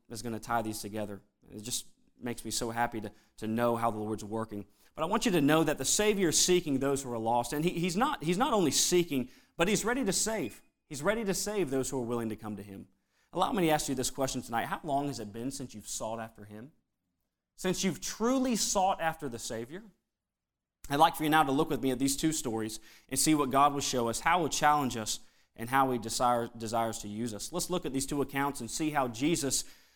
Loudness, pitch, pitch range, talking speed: -31 LUFS, 135 Hz, 115-160 Hz, 250 wpm